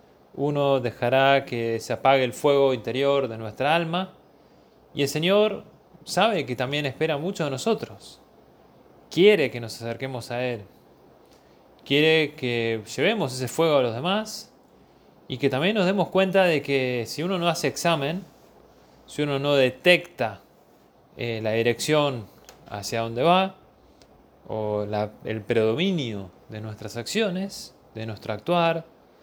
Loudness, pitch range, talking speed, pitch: -24 LUFS, 115-170 Hz, 140 wpm, 140 Hz